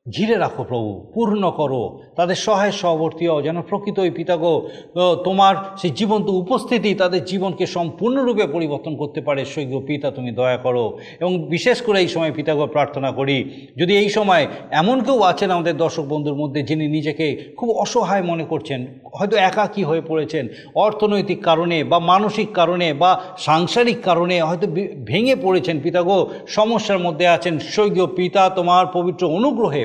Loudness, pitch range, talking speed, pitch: -19 LUFS, 155-200 Hz, 150 wpm, 175 Hz